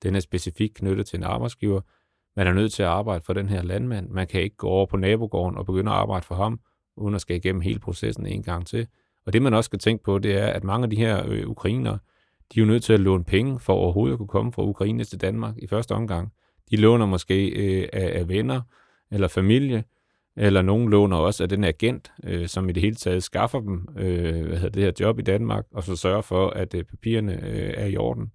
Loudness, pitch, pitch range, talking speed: -24 LUFS, 100 Hz, 95-110 Hz, 245 wpm